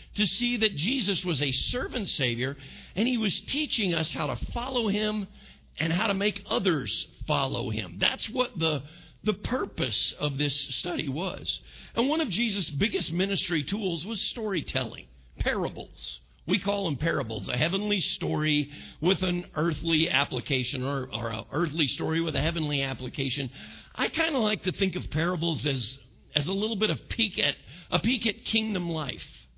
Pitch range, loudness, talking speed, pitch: 140-205 Hz, -28 LUFS, 170 wpm, 165 Hz